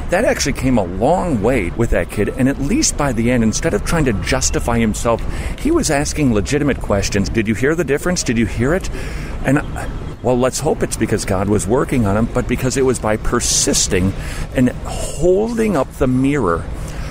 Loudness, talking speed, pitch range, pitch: -17 LUFS, 200 wpm, 105-135 Hz, 120 Hz